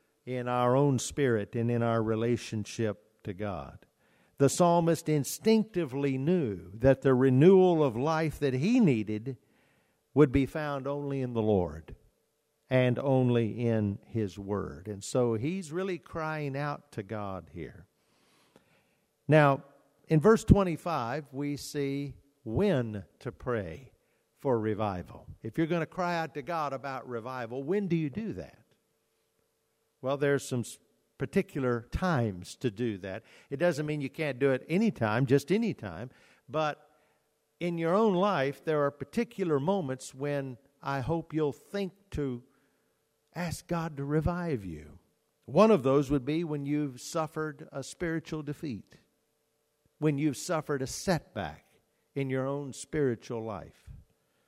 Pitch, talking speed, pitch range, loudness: 140 Hz, 140 wpm, 120-155 Hz, -30 LUFS